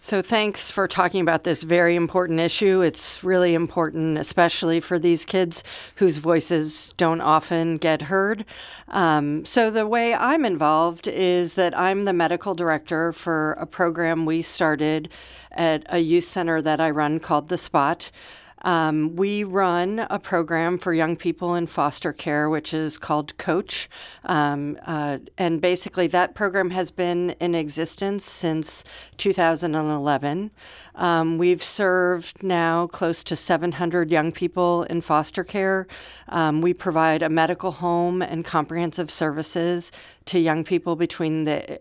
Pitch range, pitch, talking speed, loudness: 160-180 Hz, 170 Hz, 145 wpm, -22 LUFS